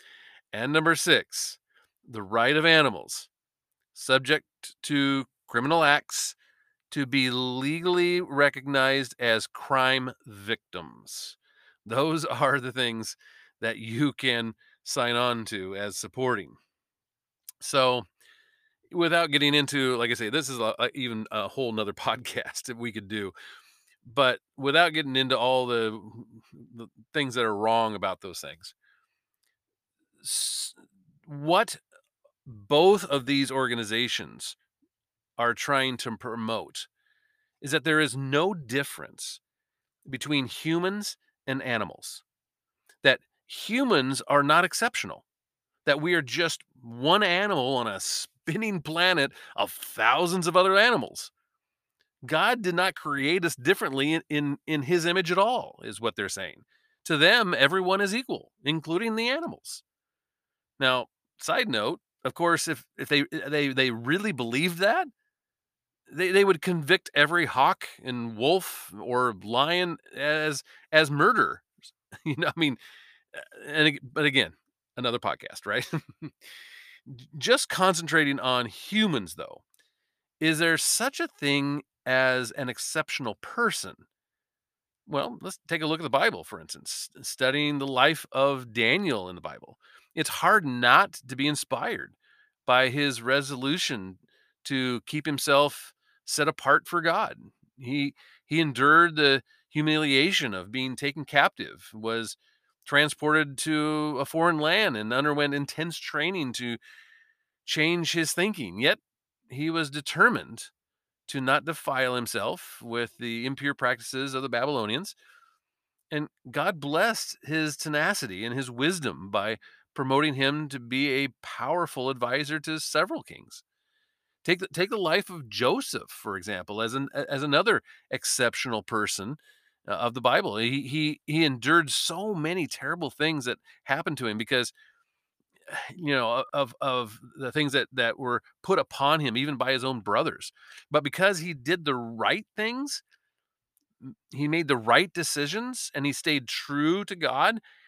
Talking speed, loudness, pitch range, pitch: 135 wpm, -26 LUFS, 130-170 Hz, 145 Hz